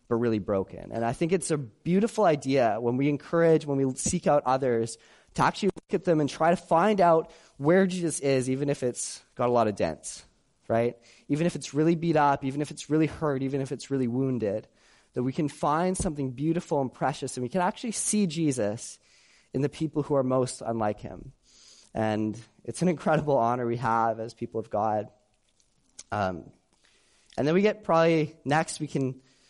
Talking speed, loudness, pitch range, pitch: 200 wpm, -27 LUFS, 120-165 Hz, 140 Hz